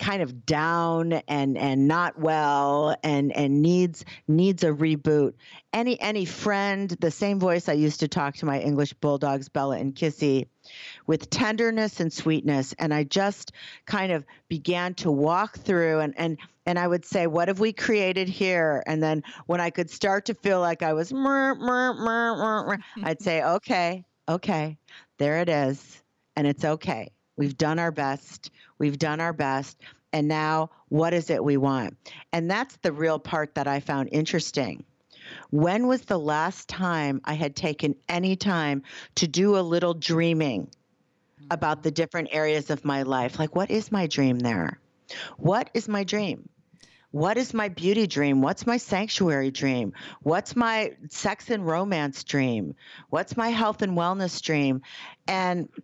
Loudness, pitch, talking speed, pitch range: -26 LUFS, 165 Hz, 170 wpm, 150-190 Hz